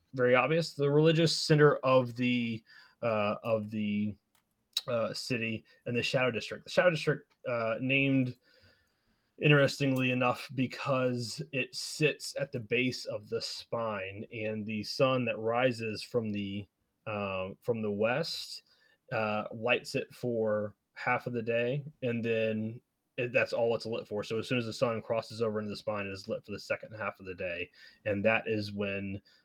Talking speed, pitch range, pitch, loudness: 170 wpm, 105-130 Hz, 115 Hz, -32 LUFS